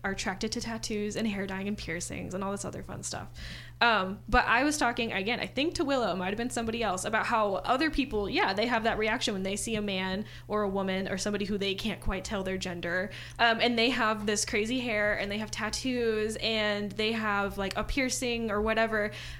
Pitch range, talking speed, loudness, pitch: 195-230 Hz, 235 wpm, -30 LUFS, 215 Hz